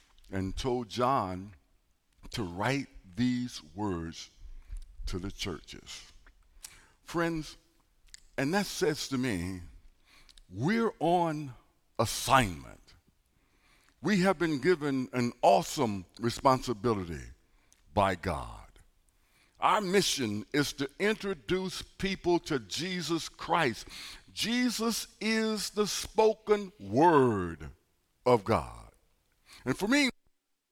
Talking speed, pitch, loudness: 90 wpm, 125 Hz, -30 LUFS